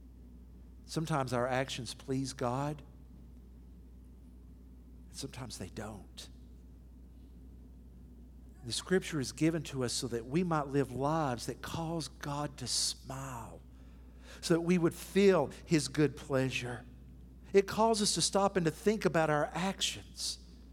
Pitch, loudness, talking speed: 120 Hz, -33 LUFS, 130 wpm